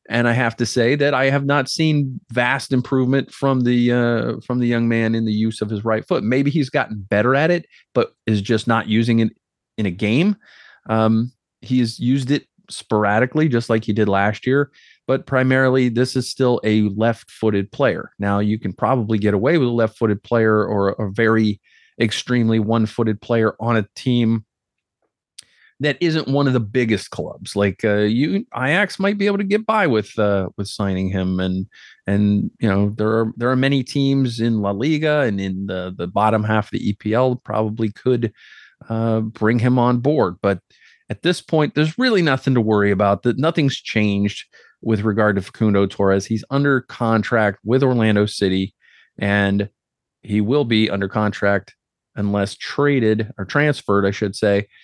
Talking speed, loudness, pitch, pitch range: 185 wpm, -19 LUFS, 115 Hz, 105-130 Hz